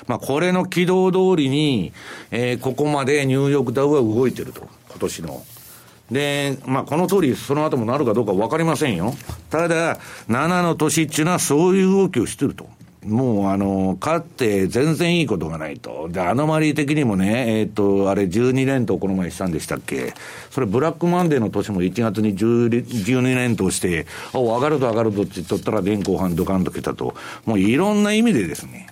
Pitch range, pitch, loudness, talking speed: 105-155 Hz, 130 Hz, -20 LUFS, 380 characters per minute